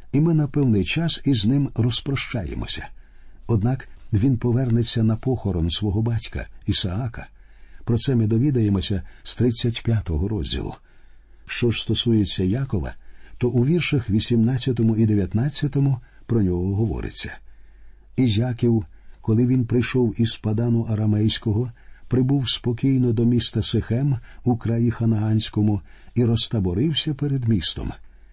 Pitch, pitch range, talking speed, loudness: 115 Hz, 105-125 Hz, 120 wpm, -22 LUFS